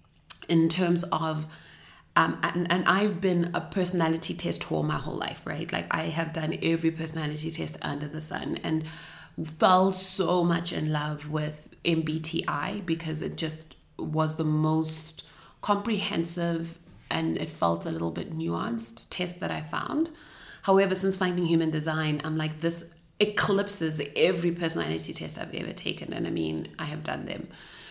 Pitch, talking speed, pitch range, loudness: 160 Hz, 160 wpm, 155-175 Hz, -27 LUFS